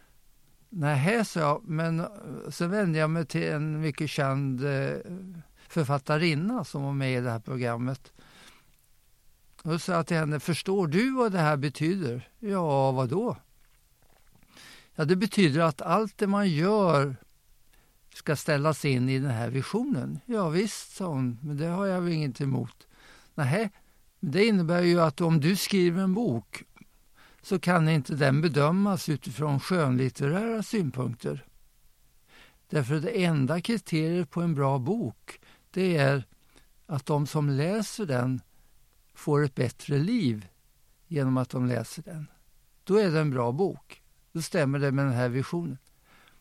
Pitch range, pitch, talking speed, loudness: 135-180 Hz, 155 Hz, 145 wpm, -27 LUFS